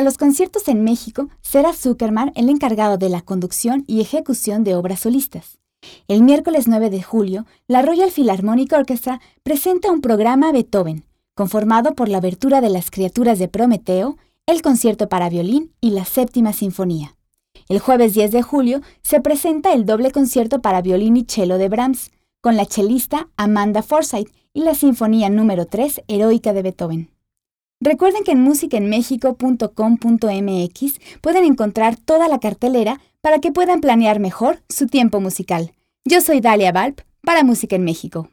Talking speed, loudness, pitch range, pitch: 155 wpm, -16 LUFS, 205-280 Hz, 235 Hz